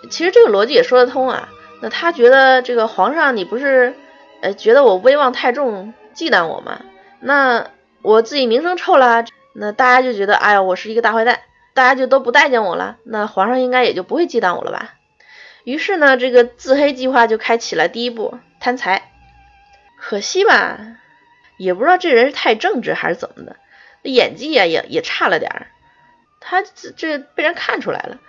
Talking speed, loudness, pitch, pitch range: 285 characters per minute, -14 LUFS, 255 Hz, 235-330 Hz